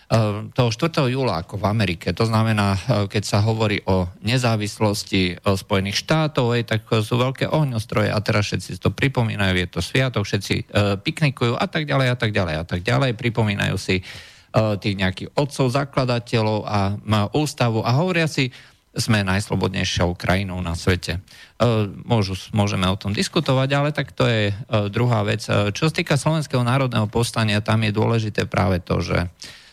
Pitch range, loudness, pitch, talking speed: 100-125 Hz, -21 LUFS, 110 Hz, 155 wpm